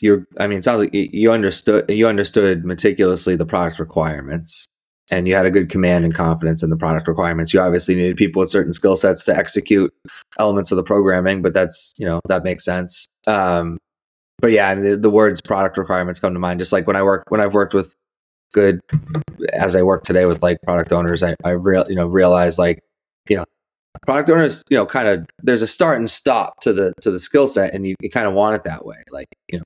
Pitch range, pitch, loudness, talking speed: 90-100 Hz, 95 Hz, -17 LUFS, 235 wpm